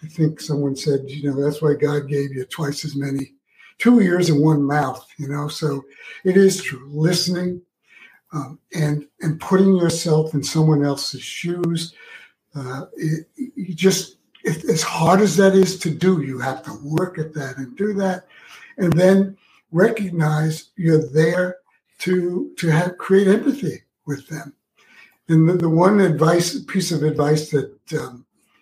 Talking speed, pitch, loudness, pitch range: 155 wpm, 160 Hz, -19 LUFS, 145-185 Hz